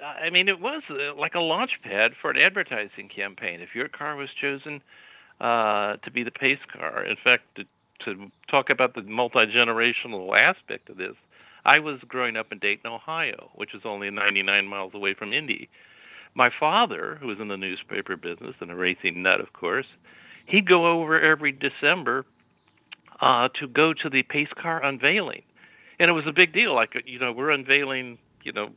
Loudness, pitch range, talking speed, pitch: -23 LUFS, 115-155 Hz, 190 wpm, 135 Hz